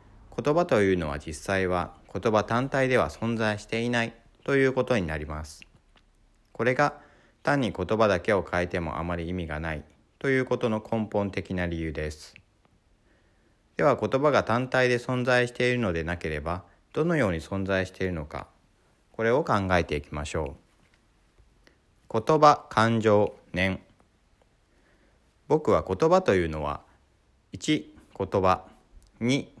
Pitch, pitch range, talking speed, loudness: 100 Hz, 85-115 Hz, 270 characters per minute, -26 LUFS